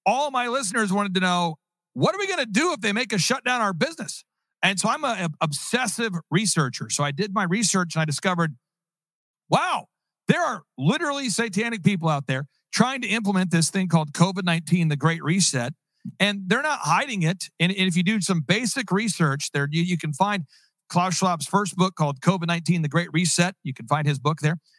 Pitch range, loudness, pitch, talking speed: 165-205 Hz, -23 LUFS, 180 Hz, 205 wpm